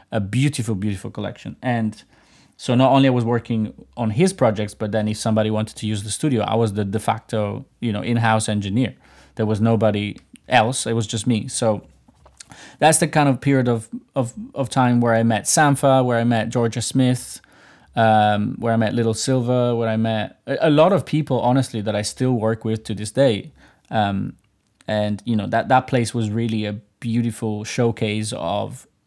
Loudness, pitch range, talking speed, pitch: -20 LUFS, 110-125 Hz, 195 wpm, 115 Hz